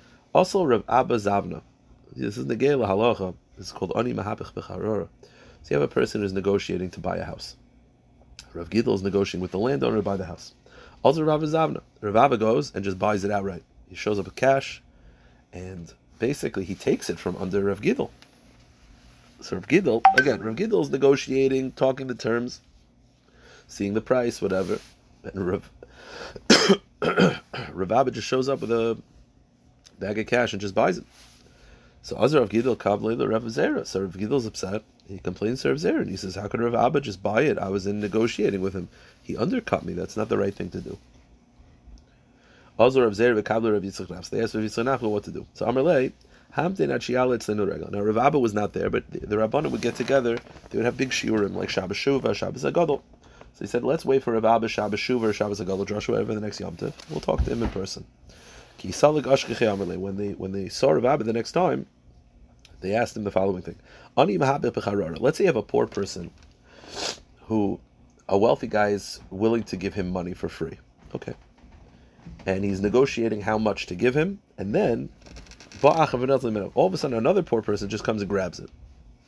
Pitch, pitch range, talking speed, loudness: 105 Hz, 95-120 Hz, 190 wpm, -25 LUFS